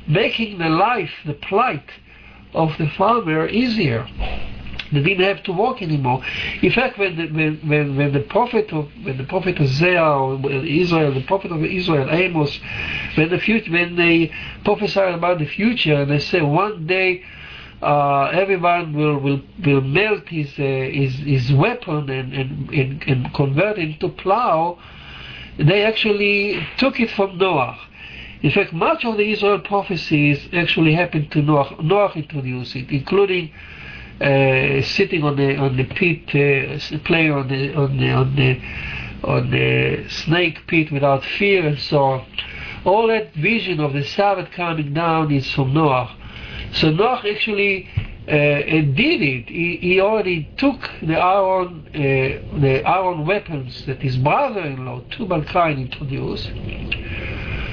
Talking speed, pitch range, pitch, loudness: 155 wpm, 135-185 Hz, 155 Hz, -19 LUFS